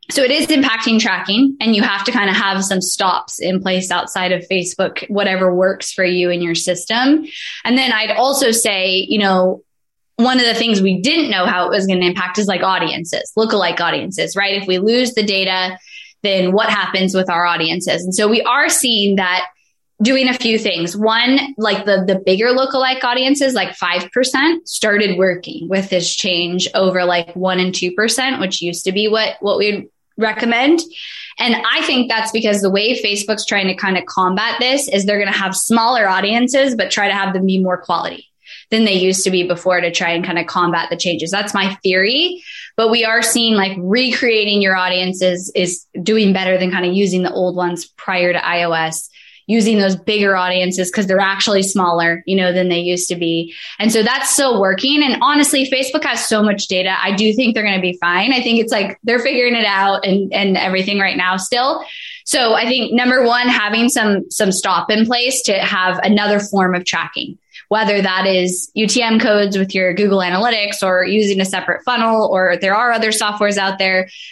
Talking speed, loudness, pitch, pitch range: 205 wpm, -15 LUFS, 200 Hz, 185-230 Hz